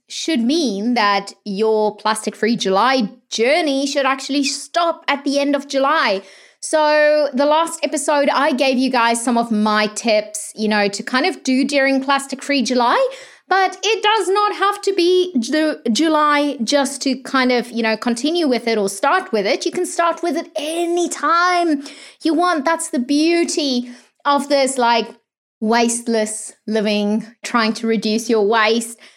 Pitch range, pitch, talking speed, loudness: 230-315 Hz, 275 Hz, 170 wpm, -17 LUFS